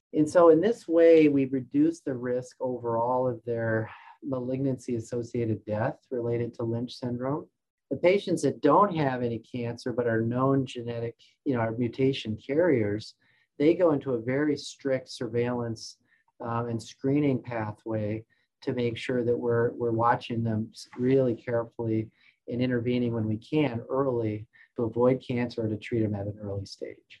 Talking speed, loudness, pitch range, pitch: 160 wpm, -28 LUFS, 115-135 Hz, 120 Hz